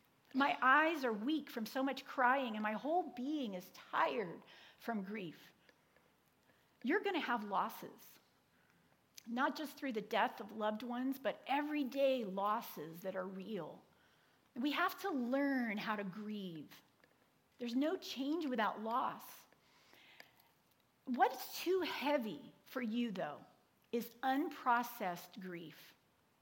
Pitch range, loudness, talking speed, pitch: 215-280 Hz, -39 LUFS, 125 wpm, 245 Hz